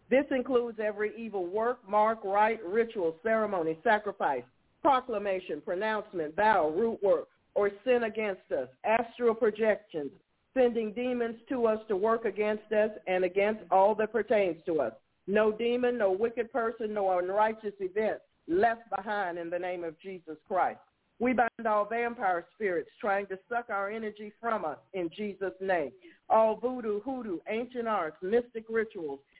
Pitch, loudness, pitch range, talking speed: 215 Hz, -30 LUFS, 195-230 Hz, 150 wpm